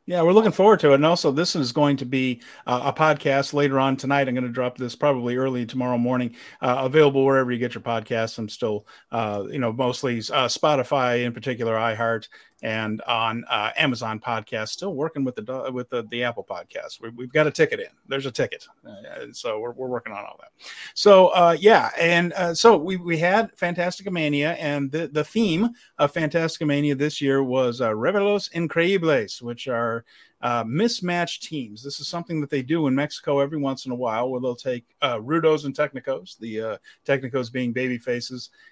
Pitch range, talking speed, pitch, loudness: 120-165 Hz, 205 wpm, 135 Hz, -22 LUFS